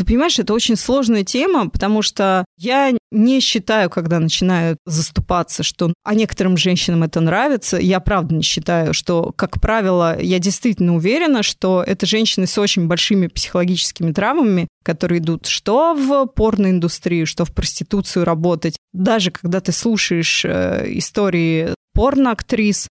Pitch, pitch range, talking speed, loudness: 185 Hz, 170-220 Hz, 140 wpm, -16 LUFS